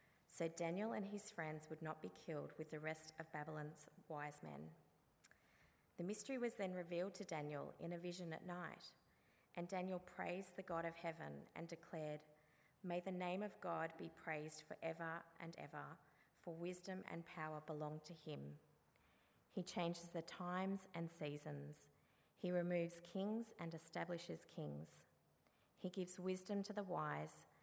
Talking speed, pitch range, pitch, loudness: 155 wpm, 155-180 Hz, 170 Hz, -49 LUFS